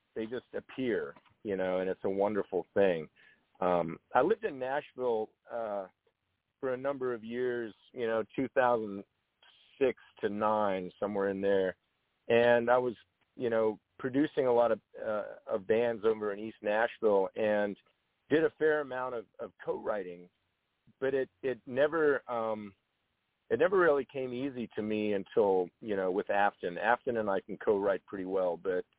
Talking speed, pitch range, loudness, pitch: 160 wpm, 100-140 Hz, -32 LUFS, 120 Hz